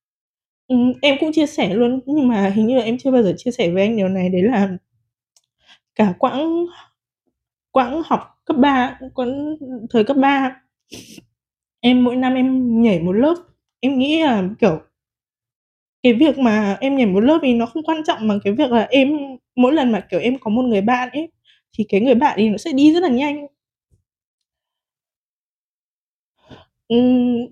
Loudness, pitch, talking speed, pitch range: -17 LUFS, 250 Hz, 180 wpm, 220-280 Hz